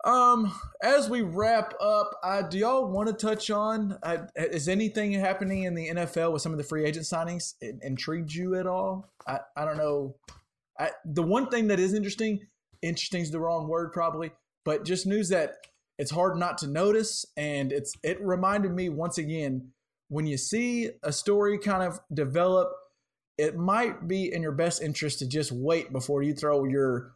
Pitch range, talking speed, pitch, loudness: 155-205 Hz, 190 wpm, 175 Hz, -28 LUFS